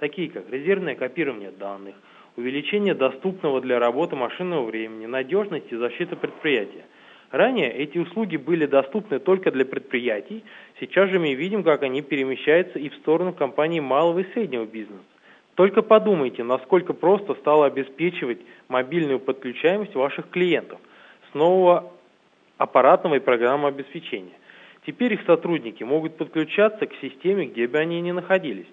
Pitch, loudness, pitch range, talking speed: 160 Hz, -22 LUFS, 130-185 Hz, 140 wpm